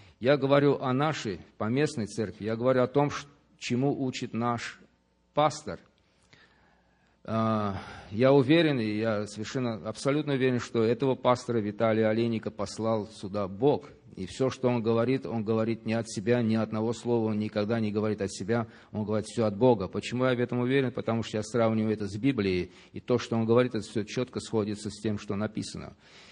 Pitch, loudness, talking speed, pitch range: 115 Hz, -28 LUFS, 180 wpm, 105-125 Hz